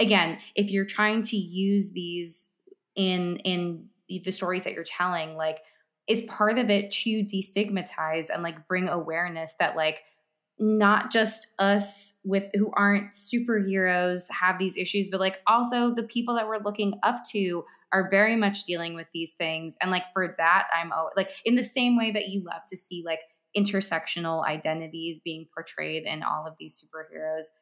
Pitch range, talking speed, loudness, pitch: 165-205 Hz, 175 wpm, -26 LUFS, 190 Hz